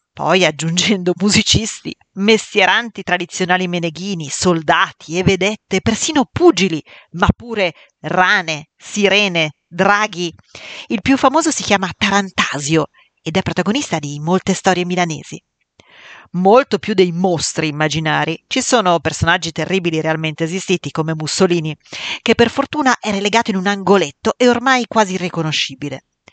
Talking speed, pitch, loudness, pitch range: 125 wpm, 185 Hz, -16 LUFS, 165-210 Hz